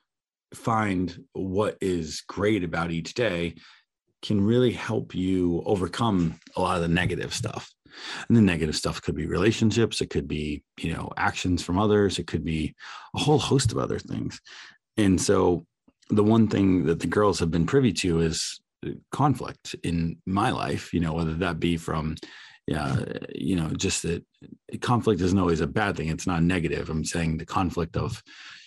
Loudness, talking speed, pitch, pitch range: -26 LUFS, 175 wpm, 85 Hz, 80-105 Hz